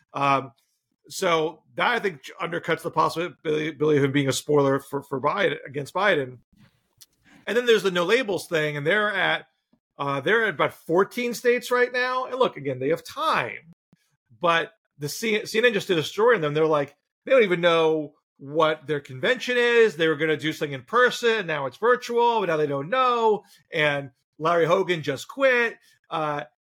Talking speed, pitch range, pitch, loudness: 190 wpm, 145-225 Hz, 160 Hz, -23 LUFS